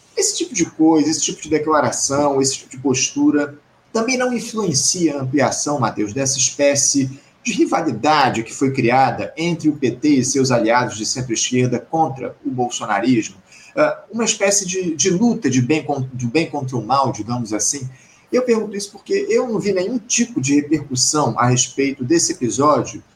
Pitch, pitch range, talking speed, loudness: 145 Hz, 130-185 Hz, 170 wpm, -18 LUFS